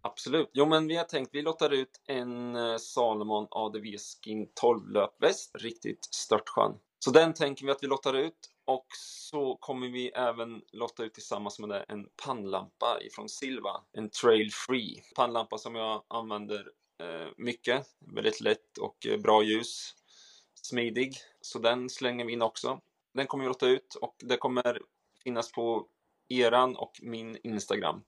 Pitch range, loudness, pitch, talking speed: 110-140 Hz, -31 LUFS, 120 Hz, 160 wpm